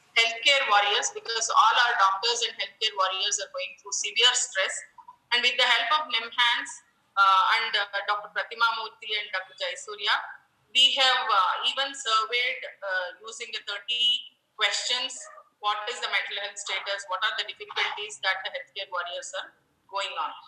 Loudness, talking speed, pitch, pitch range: -25 LUFS, 165 wpm, 225 Hz, 200-255 Hz